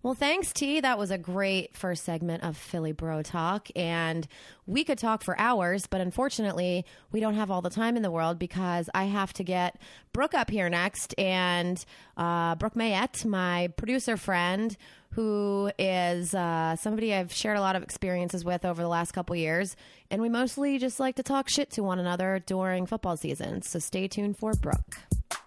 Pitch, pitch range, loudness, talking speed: 190 Hz, 175-220 Hz, -29 LUFS, 190 wpm